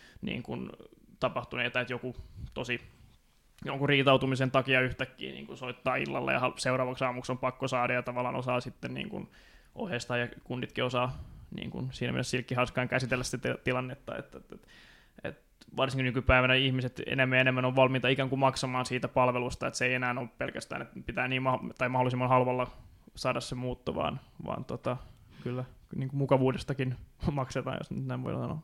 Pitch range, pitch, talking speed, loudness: 125-130 Hz, 125 Hz, 170 wpm, -31 LUFS